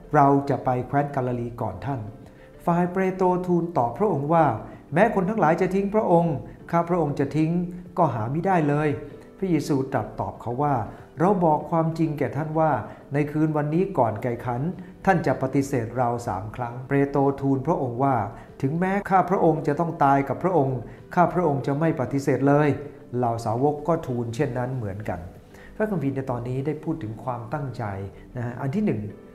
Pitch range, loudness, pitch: 125-165 Hz, -24 LUFS, 140 Hz